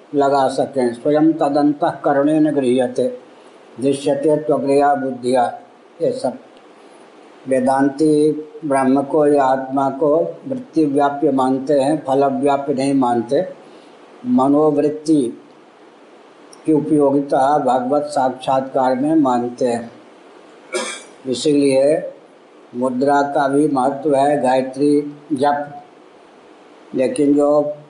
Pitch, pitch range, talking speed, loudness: 140 Hz, 135-150 Hz, 90 wpm, -17 LUFS